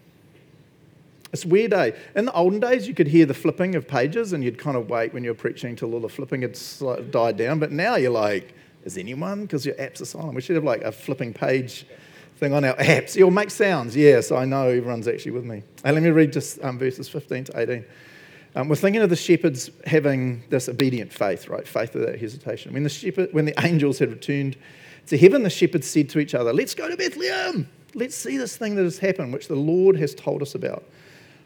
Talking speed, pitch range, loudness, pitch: 235 wpm, 130-175 Hz, -22 LUFS, 150 Hz